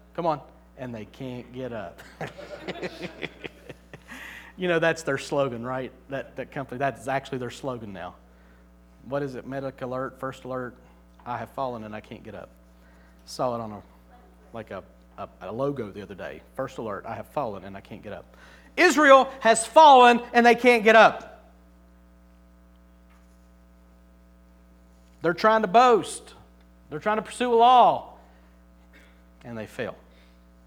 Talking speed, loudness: 155 wpm, -22 LUFS